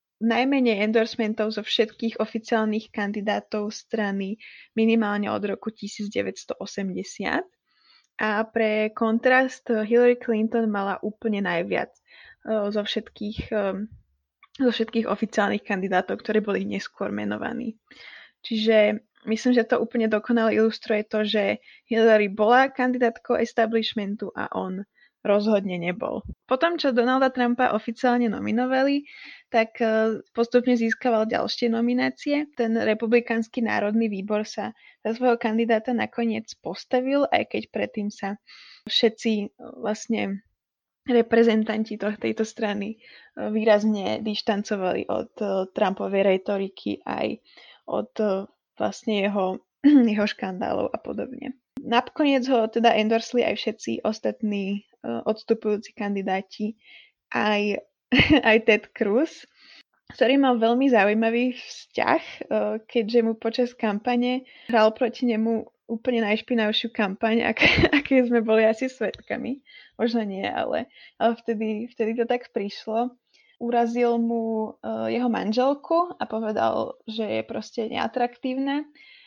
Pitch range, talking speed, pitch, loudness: 210-245 Hz, 105 wpm, 225 Hz, -24 LUFS